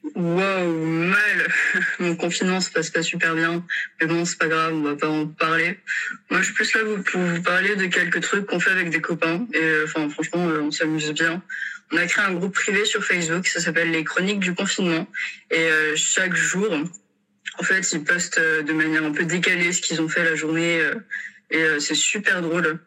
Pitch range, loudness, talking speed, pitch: 160-185 Hz, -21 LUFS, 200 wpm, 170 Hz